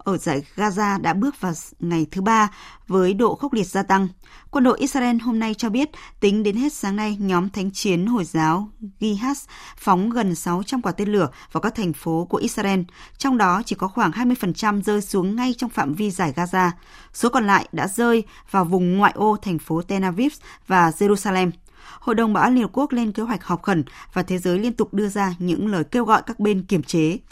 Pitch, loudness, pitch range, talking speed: 205 Hz, -21 LUFS, 180-225 Hz, 220 wpm